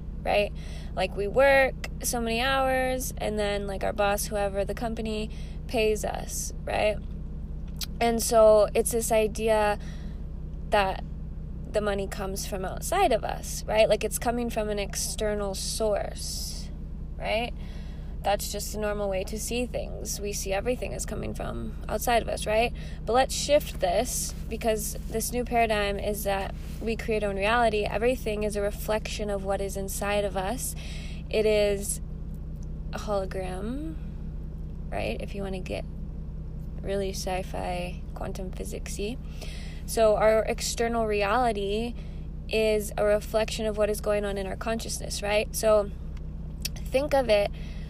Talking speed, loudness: 150 wpm, -28 LUFS